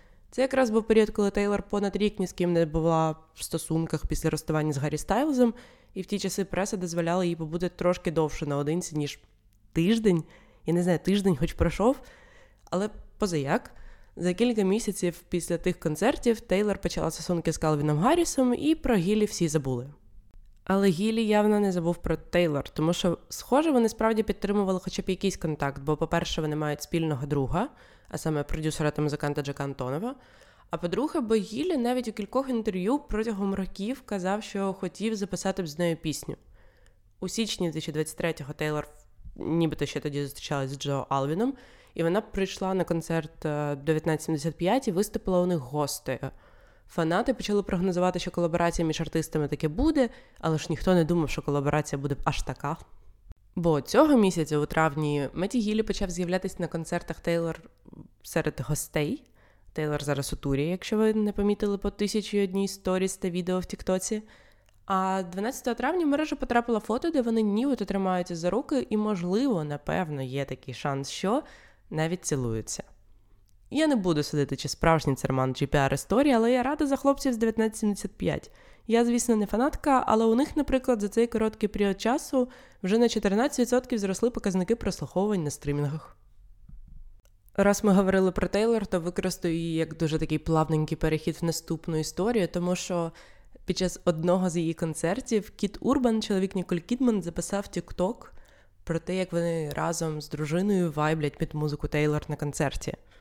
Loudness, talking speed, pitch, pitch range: -28 LUFS, 165 wpm, 180 Hz, 155-210 Hz